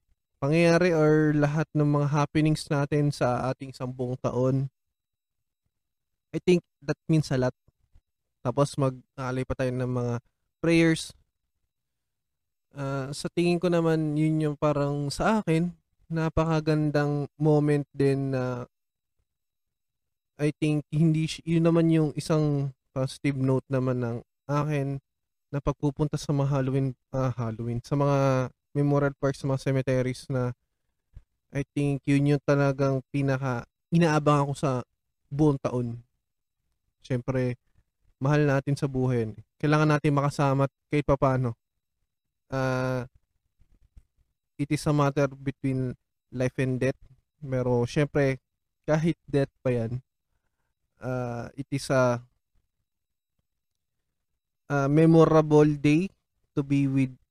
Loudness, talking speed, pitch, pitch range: -26 LUFS, 120 wpm, 140 Hz, 130-150 Hz